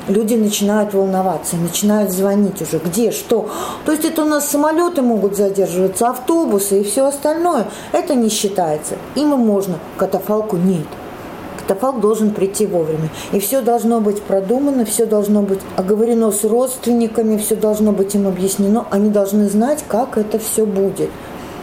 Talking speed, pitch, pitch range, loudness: 155 wpm, 210 Hz, 195-235 Hz, -16 LUFS